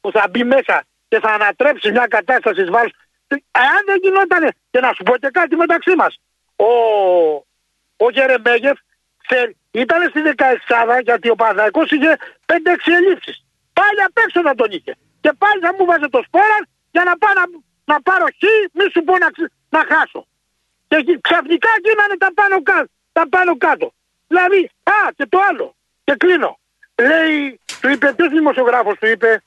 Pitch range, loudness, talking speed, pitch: 245-370 Hz, -14 LUFS, 160 wpm, 320 Hz